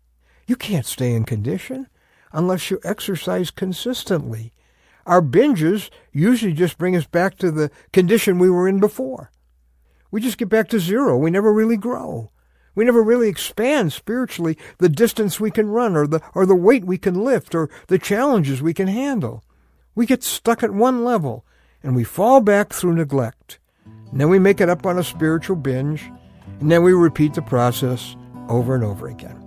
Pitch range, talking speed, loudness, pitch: 130-215 Hz, 180 wpm, -18 LUFS, 180 Hz